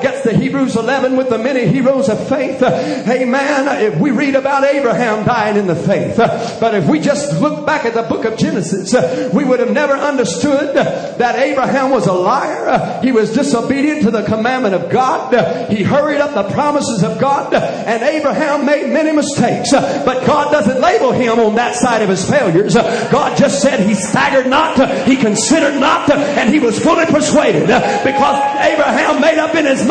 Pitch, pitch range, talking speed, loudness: 260 Hz, 225-280 Hz, 190 wpm, -13 LUFS